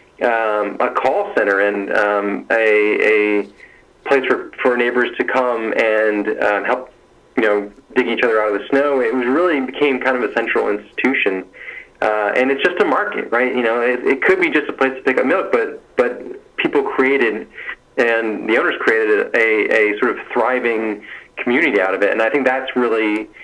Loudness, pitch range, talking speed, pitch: -17 LUFS, 110-145 Hz, 200 wpm, 125 Hz